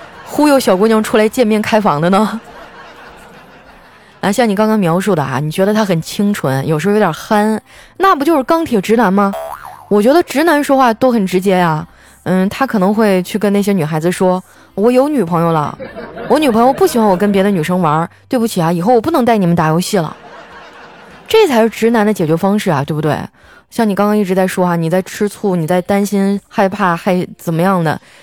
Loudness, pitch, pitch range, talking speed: -13 LUFS, 200 Hz, 180-225 Hz, 305 characters per minute